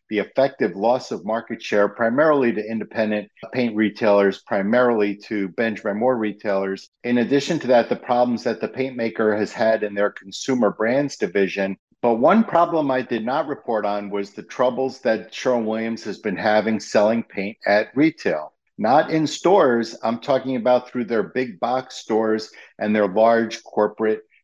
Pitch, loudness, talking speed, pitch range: 115 Hz, -21 LUFS, 170 wpm, 105-125 Hz